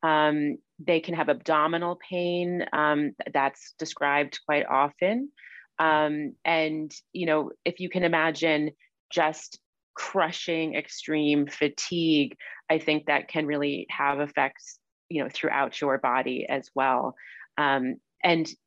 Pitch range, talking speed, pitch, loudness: 150-170 Hz, 120 wpm, 155 Hz, -26 LUFS